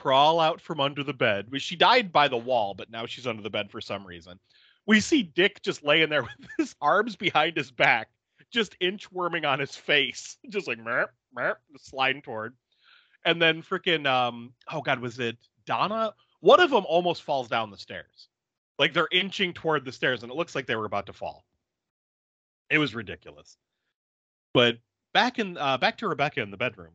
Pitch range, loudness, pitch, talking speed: 120-175 Hz, -25 LUFS, 140 Hz, 195 wpm